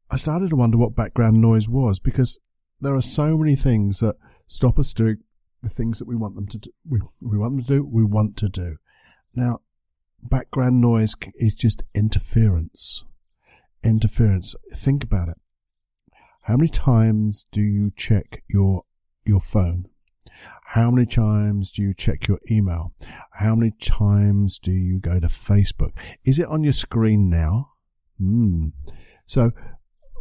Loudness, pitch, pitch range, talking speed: -21 LUFS, 110 Hz, 95-120 Hz, 160 wpm